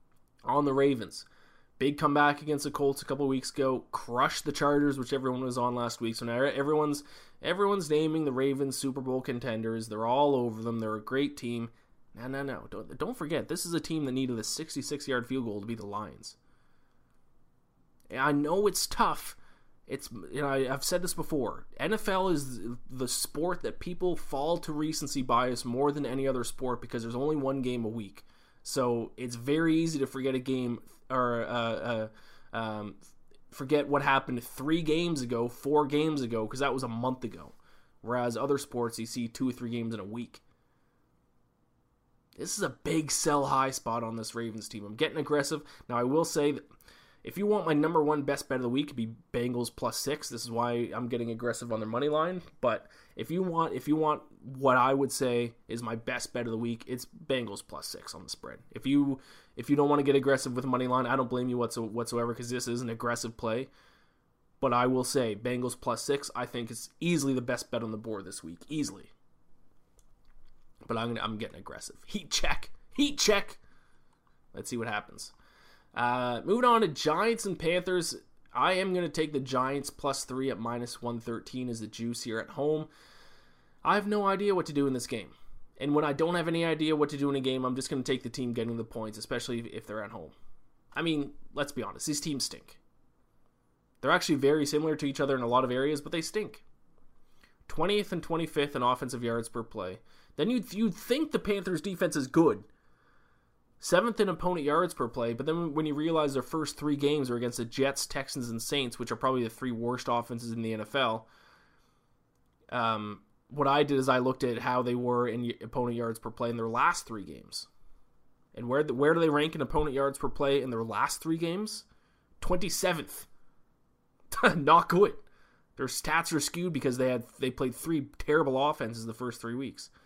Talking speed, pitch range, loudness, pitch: 210 wpm, 120-150 Hz, -31 LUFS, 130 Hz